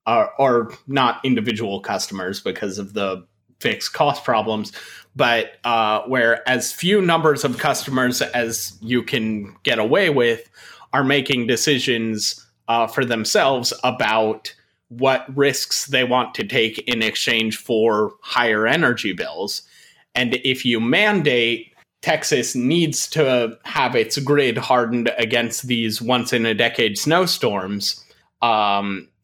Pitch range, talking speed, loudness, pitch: 110-140 Hz, 130 wpm, -19 LUFS, 125 Hz